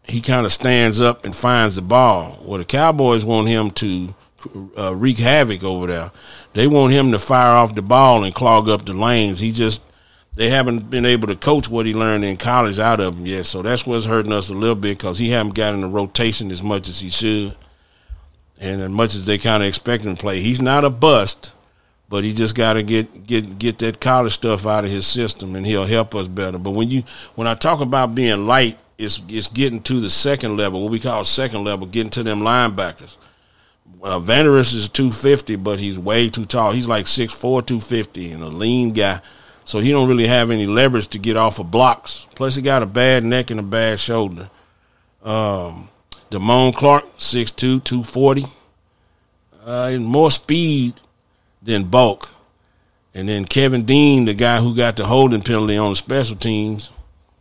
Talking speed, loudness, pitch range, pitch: 200 wpm, -17 LUFS, 100-125 Hz, 110 Hz